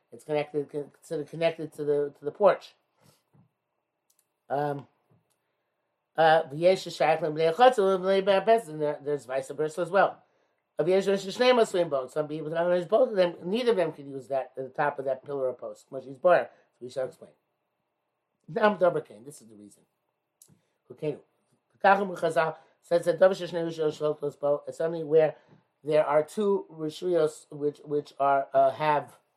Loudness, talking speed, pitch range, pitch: -27 LUFS, 110 wpm, 145-175 Hz, 155 Hz